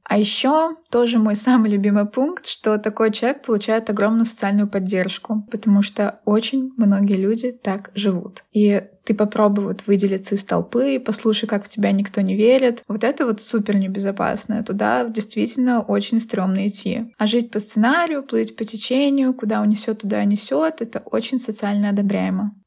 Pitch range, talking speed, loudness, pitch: 205-235 Hz, 160 wpm, -19 LUFS, 215 Hz